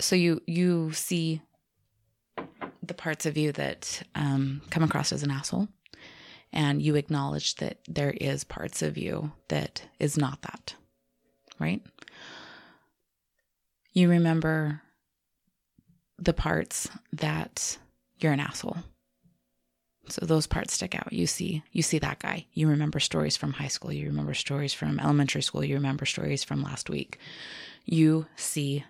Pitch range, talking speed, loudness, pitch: 110-160 Hz, 140 wpm, -29 LUFS, 150 Hz